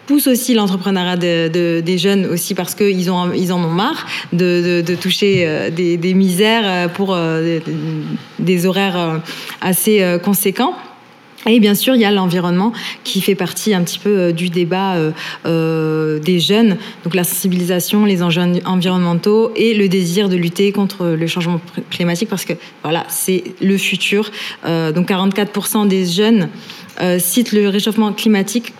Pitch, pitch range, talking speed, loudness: 185 Hz, 175-205 Hz, 155 wpm, -15 LUFS